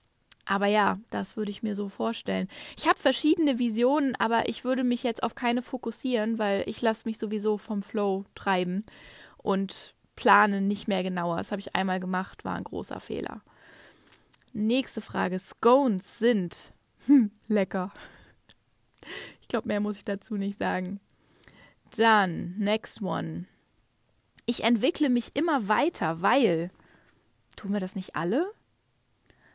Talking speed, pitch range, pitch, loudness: 140 wpm, 185-235 Hz, 205 Hz, -27 LUFS